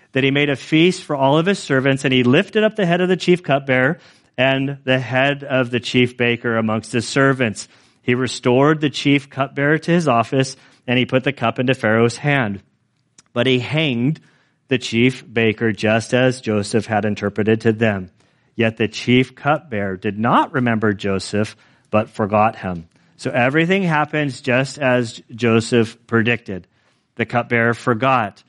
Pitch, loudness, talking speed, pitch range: 125 Hz, -18 LUFS, 170 wpm, 115-140 Hz